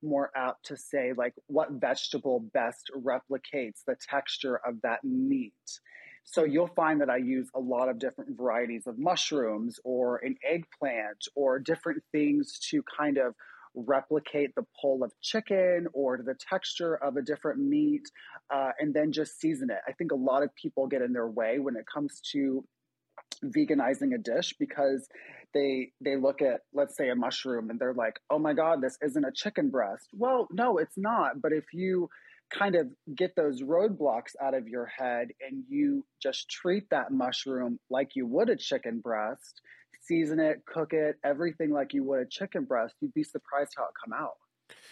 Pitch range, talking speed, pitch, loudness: 130-200 Hz, 185 wpm, 150 Hz, -31 LUFS